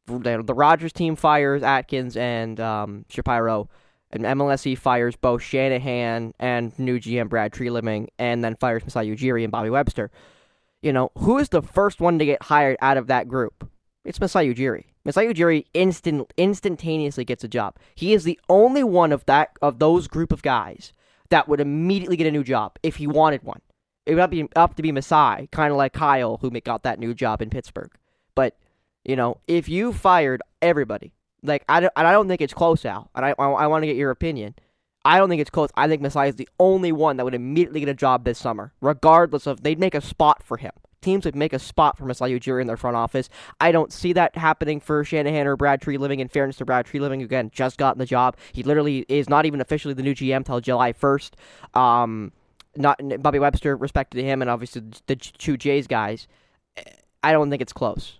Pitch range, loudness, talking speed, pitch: 125-155 Hz, -21 LUFS, 215 wpm, 140 Hz